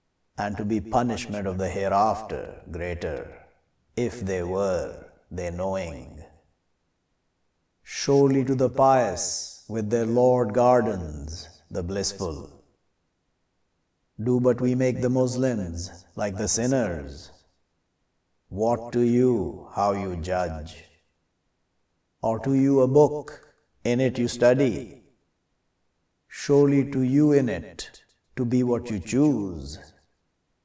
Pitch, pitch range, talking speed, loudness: 100 Hz, 85-125 Hz, 110 wpm, -24 LUFS